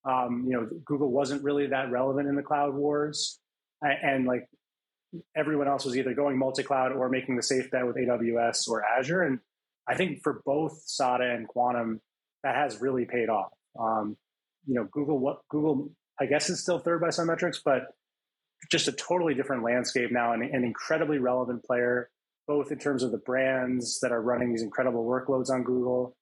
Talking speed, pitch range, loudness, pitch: 190 wpm, 125-145 Hz, -28 LUFS, 130 Hz